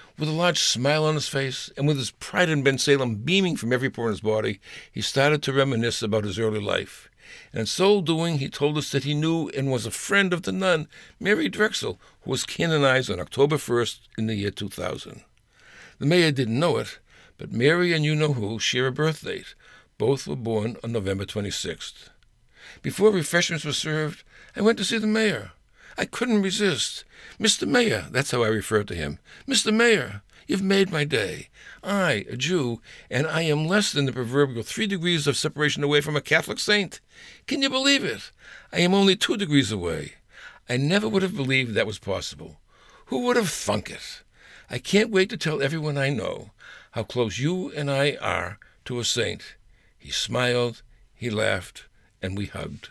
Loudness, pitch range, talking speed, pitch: -24 LUFS, 115-175 Hz, 195 wpm, 140 Hz